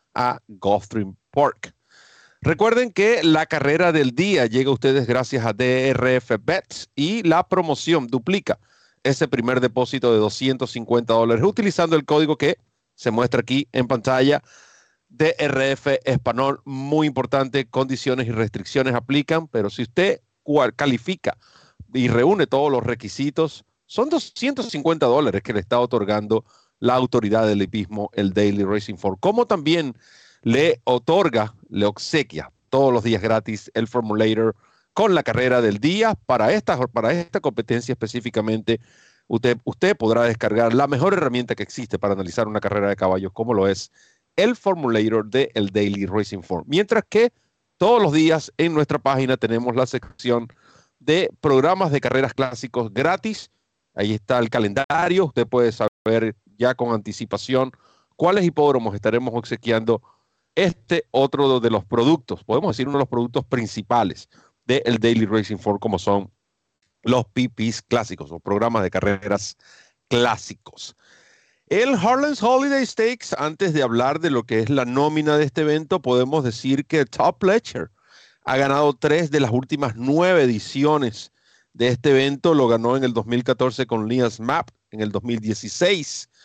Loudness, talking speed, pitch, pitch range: -21 LUFS, 150 wpm, 125 Hz, 115-150 Hz